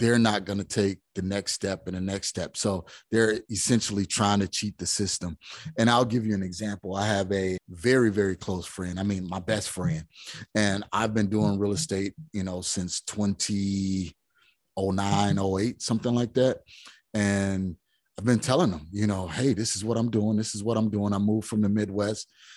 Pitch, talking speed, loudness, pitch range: 100 Hz, 195 wpm, -27 LUFS, 95-110 Hz